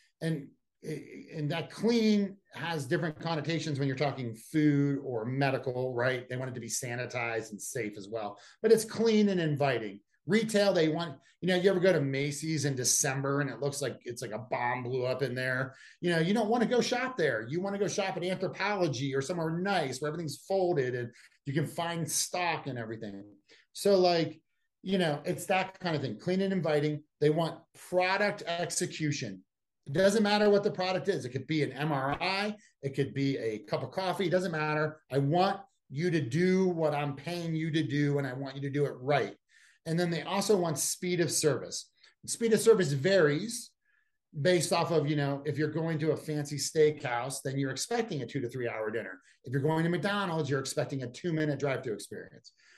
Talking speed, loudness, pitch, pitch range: 210 wpm, -31 LUFS, 155 Hz, 140-185 Hz